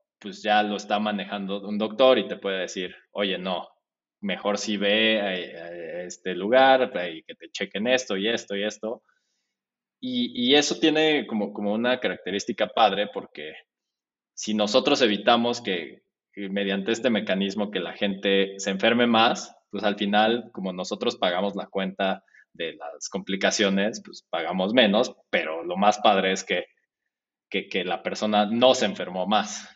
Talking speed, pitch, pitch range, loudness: 165 wpm, 105 Hz, 100-120 Hz, -24 LUFS